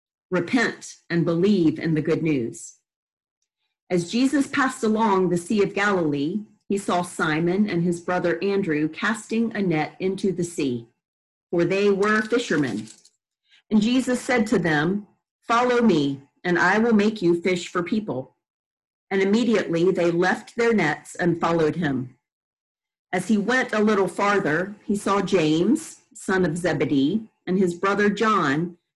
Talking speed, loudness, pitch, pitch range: 150 wpm, -22 LUFS, 190 Hz, 170-215 Hz